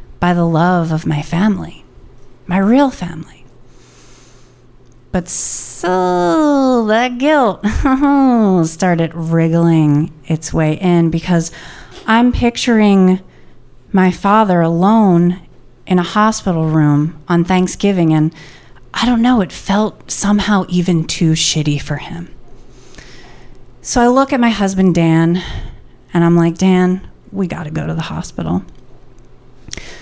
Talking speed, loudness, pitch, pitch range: 120 wpm, -14 LUFS, 170 Hz, 150-200 Hz